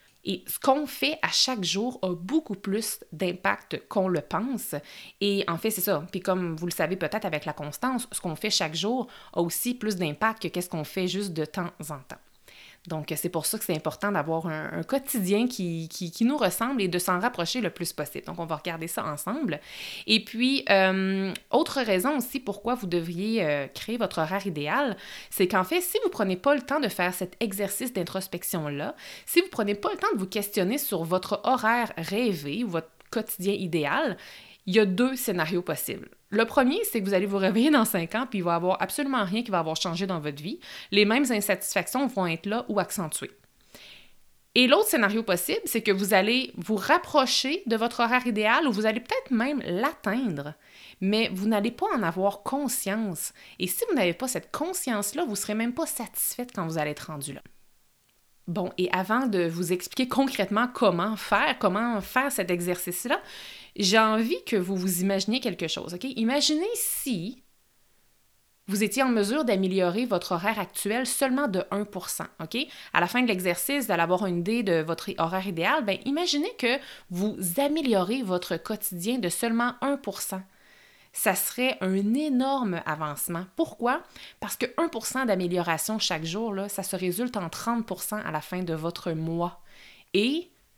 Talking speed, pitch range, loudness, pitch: 190 wpm, 180-245 Hz, -27 LUFS, 205 Hz